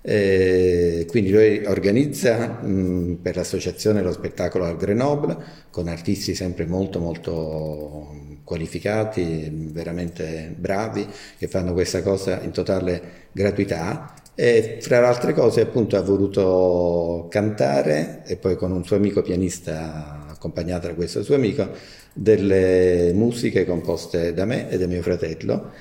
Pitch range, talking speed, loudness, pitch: 85-100 Hz, 130 wpm, -21 LUFS, 90 Hz